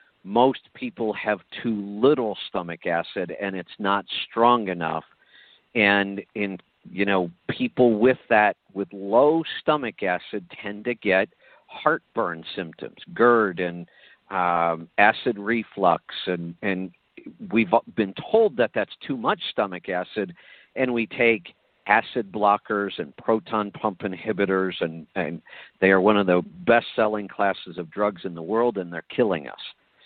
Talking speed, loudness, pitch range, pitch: 145 wpm, -24 LUFS, 95-115 Hz, 105 Hz